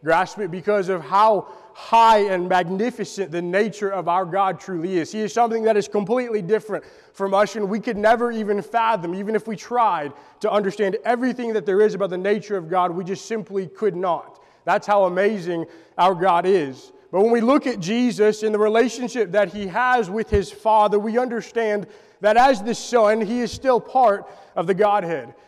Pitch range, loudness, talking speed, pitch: 195-225 Hz, -21 LUFS, 200 wpm, 210 Hz